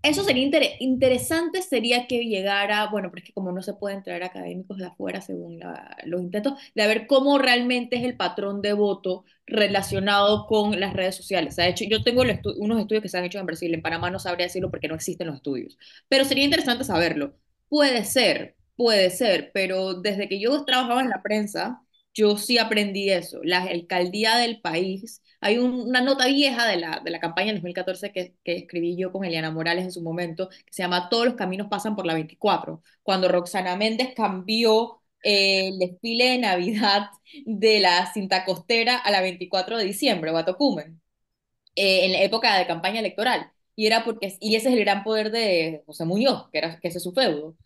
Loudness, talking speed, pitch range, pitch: -23 LUFS, 205 wpm, 180-235 Hz, 200 Hz